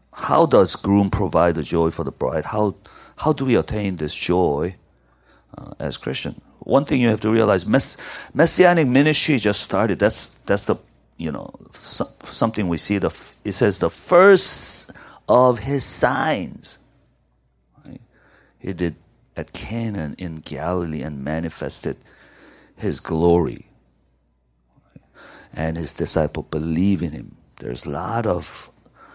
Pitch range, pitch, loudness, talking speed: 75-115 Hz, 90 Hz, -20 LUFS, 140 wpm